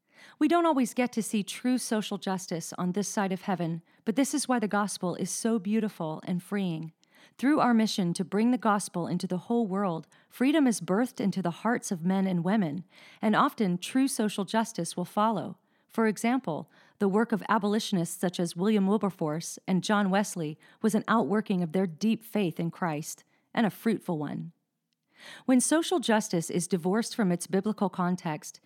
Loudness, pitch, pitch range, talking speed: -29 LUFS, 200 Hz, 180-225 Hz, 185 wpm